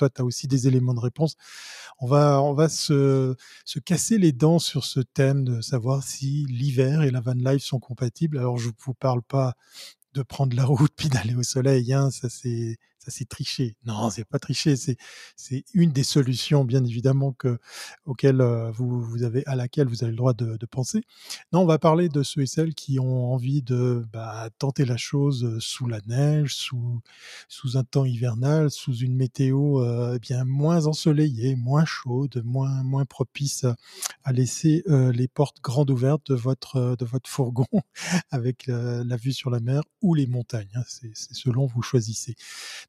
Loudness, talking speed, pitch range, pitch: -24 LUFS, 195 wpm, 125-140 Hz, 130 Hz